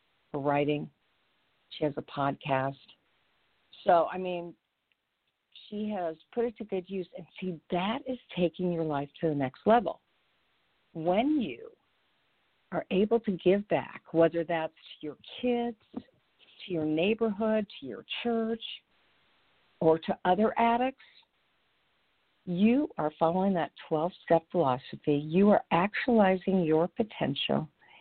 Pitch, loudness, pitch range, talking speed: 180 Hz, -29 LUFS, 160-225 Hz, 130 wpm